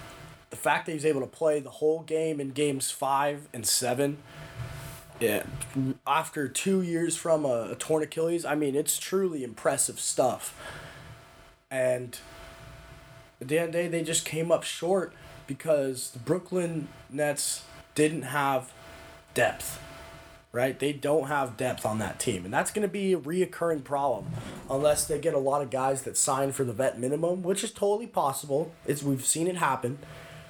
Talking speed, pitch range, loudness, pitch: 170 wpm, 135-165 Hz, -28 LUFS, 145 Hz